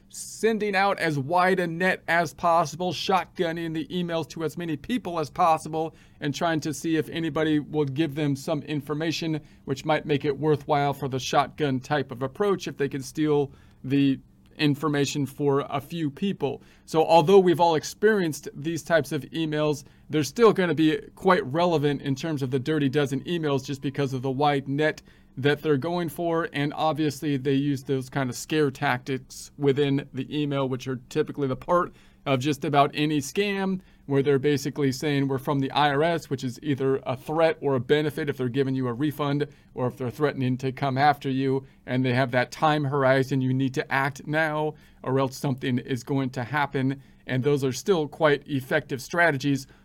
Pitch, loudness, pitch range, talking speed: 145 Hz, -25 LUFS, 135-160 Hz, 190 wpm